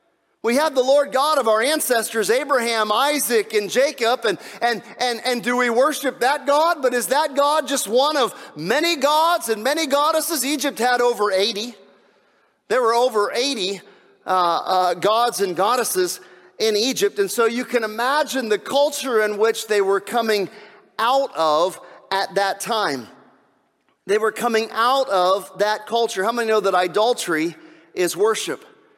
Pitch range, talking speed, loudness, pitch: 210-280 Hz, 165 wpm, -20 LUFS, 235 Hz